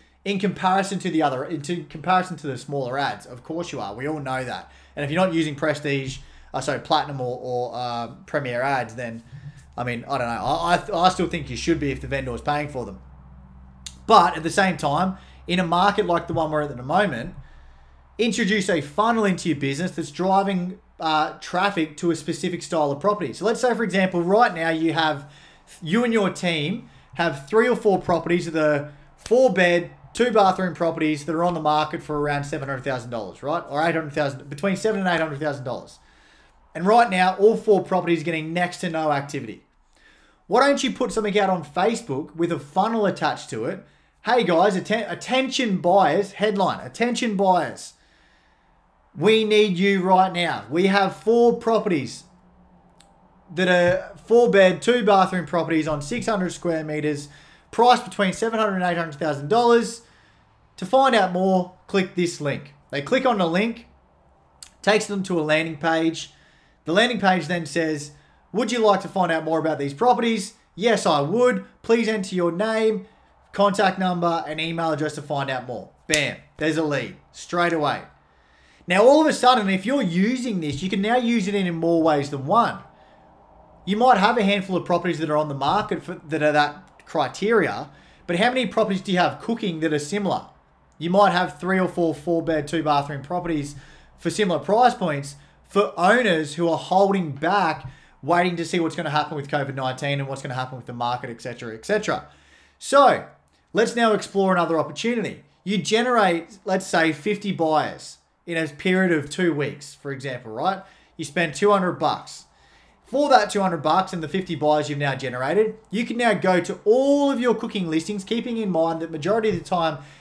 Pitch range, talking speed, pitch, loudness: 150-200 Hz, 190 wpm, 175 Hz, -22 LUFS